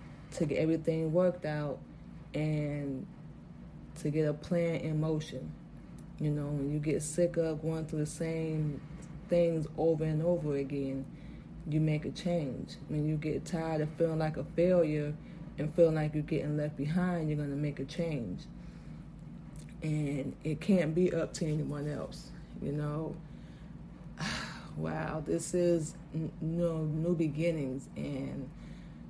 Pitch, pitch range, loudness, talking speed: 155 Hz, 150-165 Hz, -34 LUFS, 150 wpm